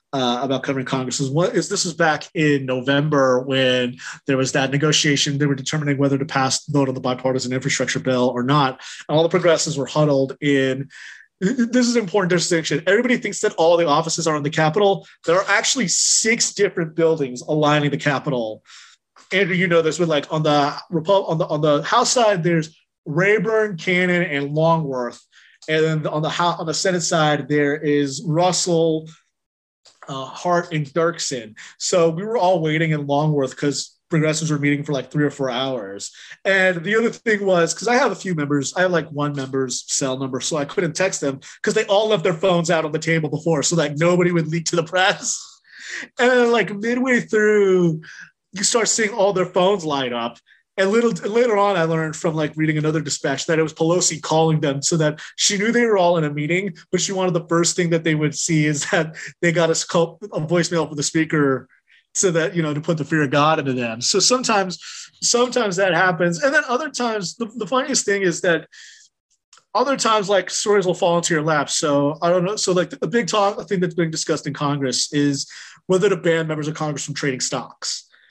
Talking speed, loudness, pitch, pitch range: 215 wpm, -19 LUFS, 165 Hz, 145-190 Hz